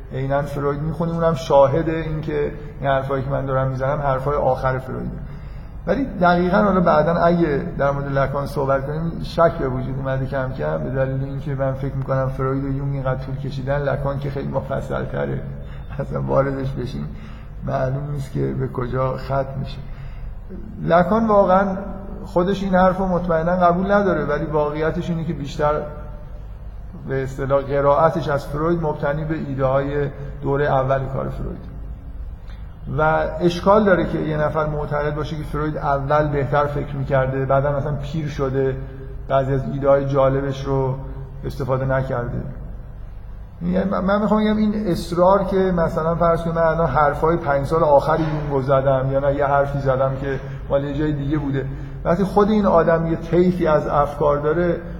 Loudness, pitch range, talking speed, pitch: -20 LUFS, 135-160 Hz, 160 wpm, 140 Hz